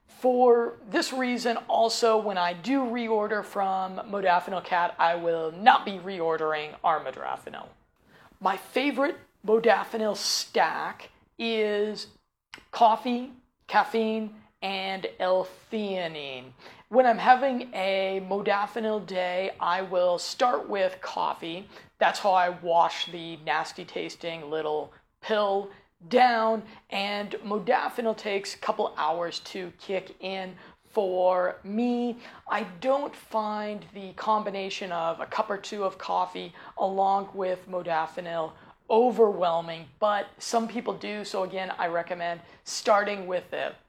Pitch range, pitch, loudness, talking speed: 175-220 Hz, 195 Hz, -27 LUFS, 115 wpm